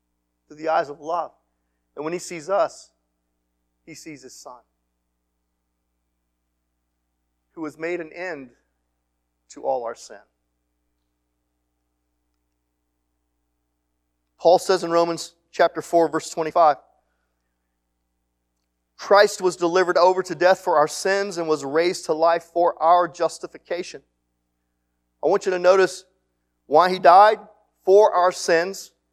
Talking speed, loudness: 120 wpm, -20 LUFS